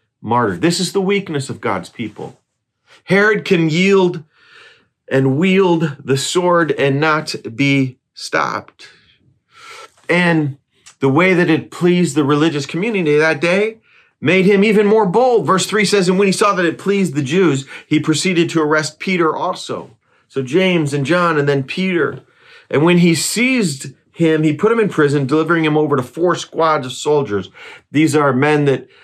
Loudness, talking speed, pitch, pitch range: -15 LUFS, 170 wpm, 165 Hz, 150-190 Hz